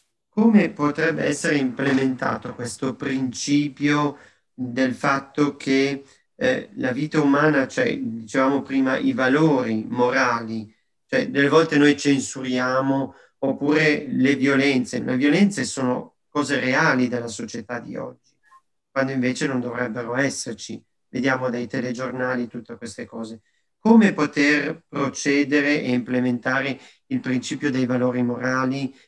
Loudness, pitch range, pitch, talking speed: -22 LUFS, 125-145 Hz, 135 Hz, 120 wpm